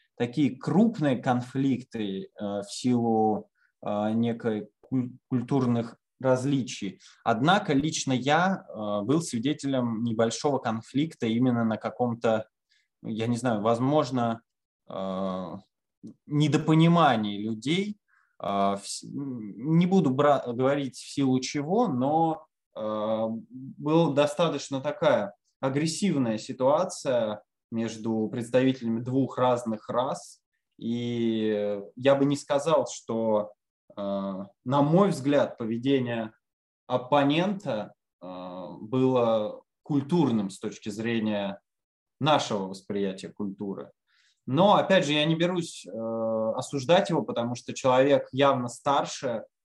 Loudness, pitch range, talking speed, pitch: -27 LUFS, 110-145 Hz, 90 wpm, 125 Hz